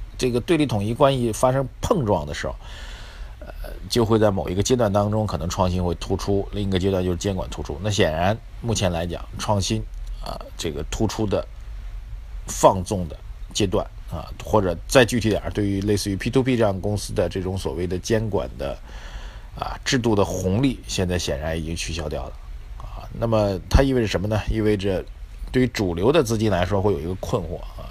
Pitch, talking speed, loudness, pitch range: 100 Hz, 295 characters per minute, -23 LUFS, 90-110 Hz